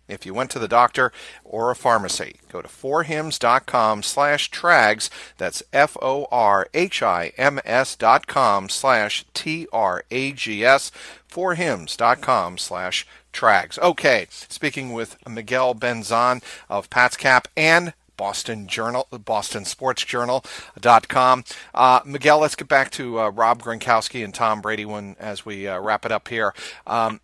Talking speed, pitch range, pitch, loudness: 125 wpm, 110-130 Hz, 120 Hz, -20 LUFS